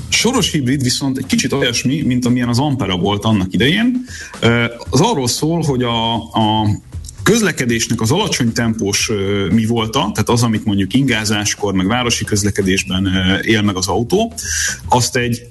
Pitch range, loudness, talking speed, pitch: 105-130 Hz, -15 LUFS, 150 wpm, 115 Hz